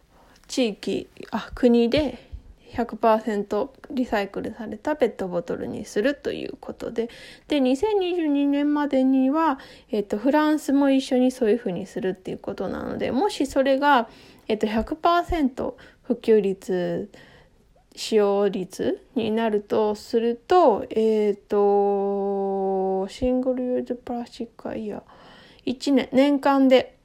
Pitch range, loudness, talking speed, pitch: 210-275 Hz, -23 LUFS, 235 characters per minute, 245 Hz